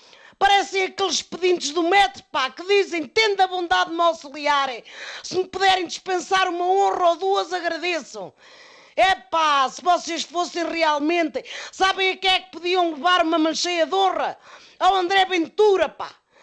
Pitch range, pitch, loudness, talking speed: 330-380 Hz, 360 Hz, -21 LUFS, 160 wpm